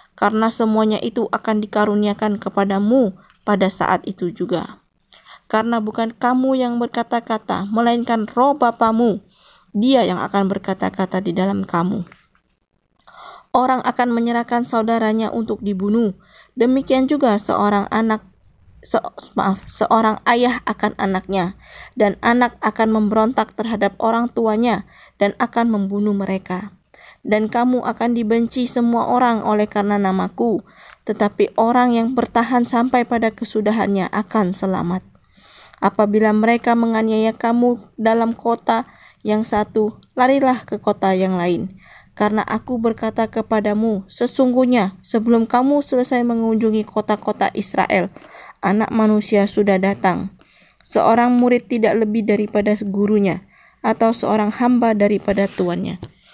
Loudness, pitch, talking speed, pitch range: -18 LUFS, 220 Hz, 115 wpm, 200-235 Hz